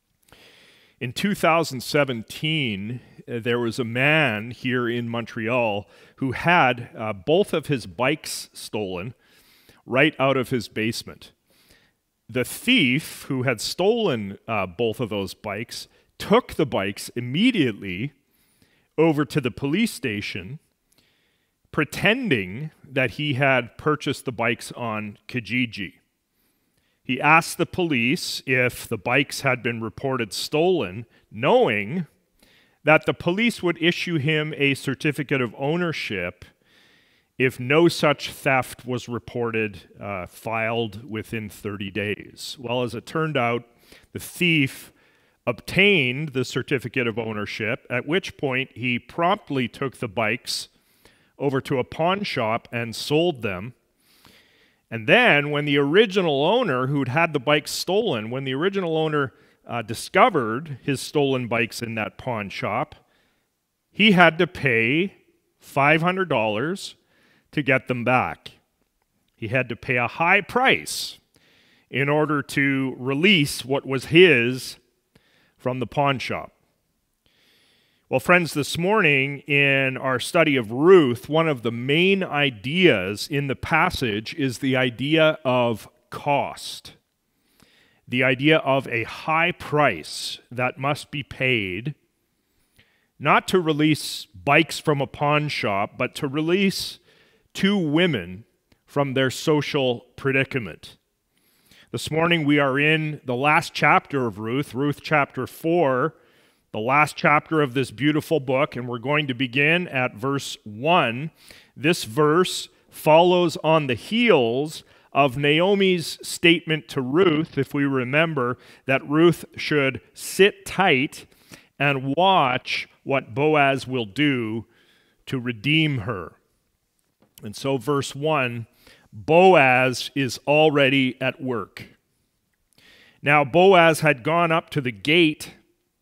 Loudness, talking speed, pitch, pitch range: -22 LUFS, 125 wpm, 135 Hz, 120-155 Hz